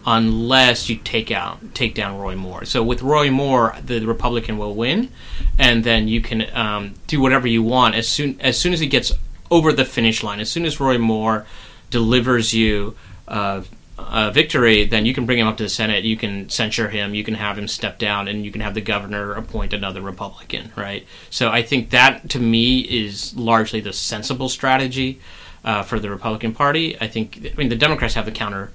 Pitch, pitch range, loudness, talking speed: 115 Hz, 105-125 Hz, -19 LUFS, 210 wpm